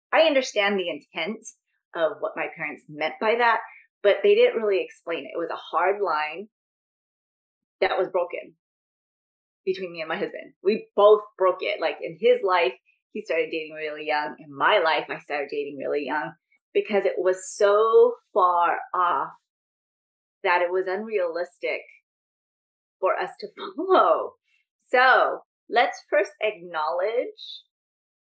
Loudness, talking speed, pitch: -24 LUFS, 145 wpm, 210 Hz